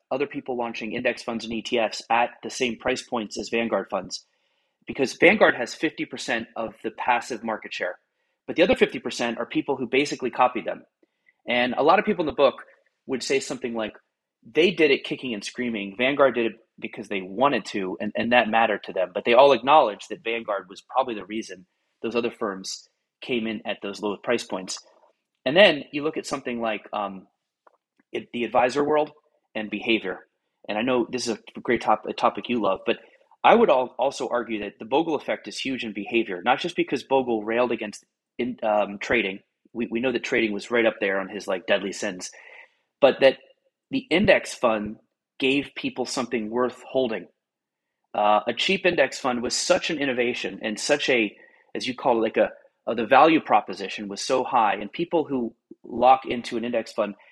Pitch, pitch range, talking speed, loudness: 120 Hz, 110-130 Hz, 200 wpm, -24 LUFS